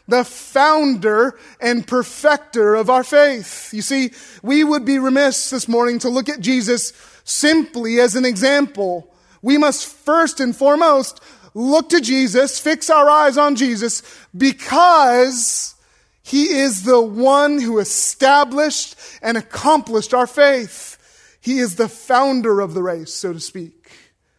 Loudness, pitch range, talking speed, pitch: -16 LUFS, 230-285 Hz, 140 wpm, 255 Hz